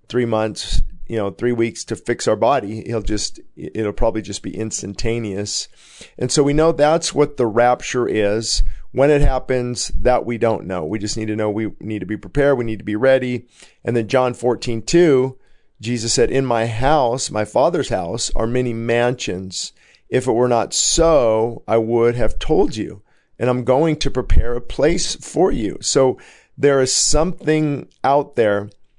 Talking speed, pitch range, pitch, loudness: 185 wpm, 110-130 Hz, 120 Hz, -19 LUFS